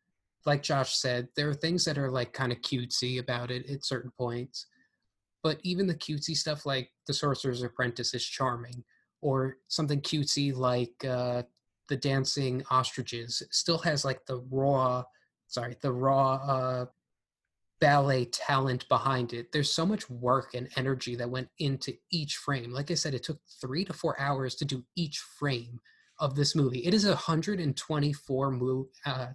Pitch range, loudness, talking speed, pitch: 125-145 Hz, -30 LUFS, 165 wpm, 135 Hz